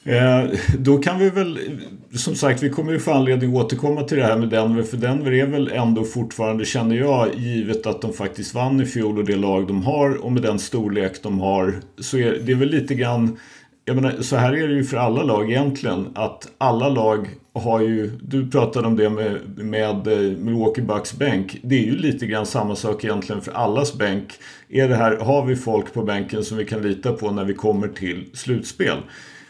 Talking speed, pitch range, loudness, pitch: 220 wpm, 105-135 Hz, -21 LUFS, 115 Hz